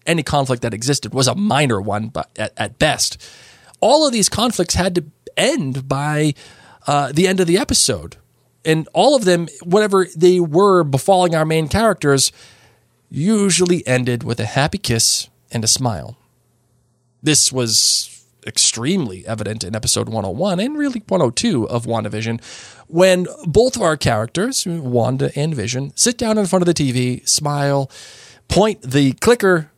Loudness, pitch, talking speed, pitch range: -17 LUFS, 140 Hz, 155 wpm, 120-180 Hz